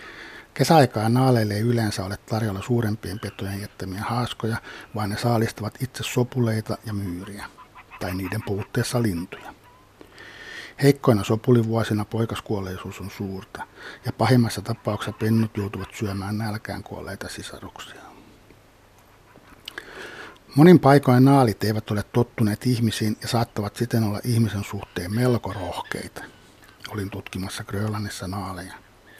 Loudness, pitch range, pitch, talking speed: -23 LUFS, 100-120 Hz, 110 Hz, 110 wpm